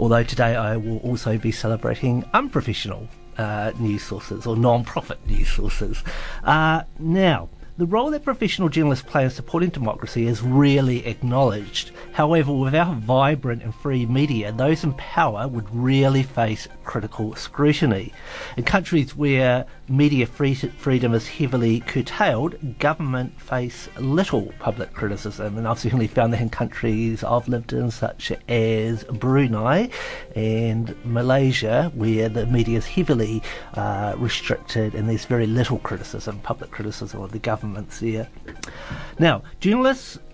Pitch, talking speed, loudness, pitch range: 120 Hz, 135 wpm, -22 LUFS, 110-140 Hz